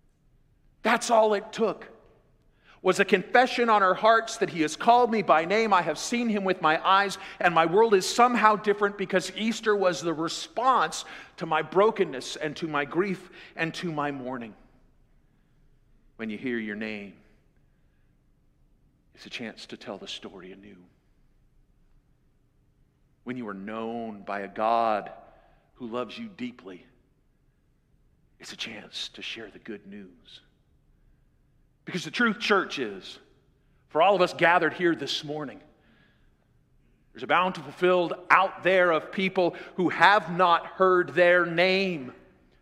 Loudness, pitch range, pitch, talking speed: -25 LUFS, 145-200 Hz, 180 Hz, 150 wpm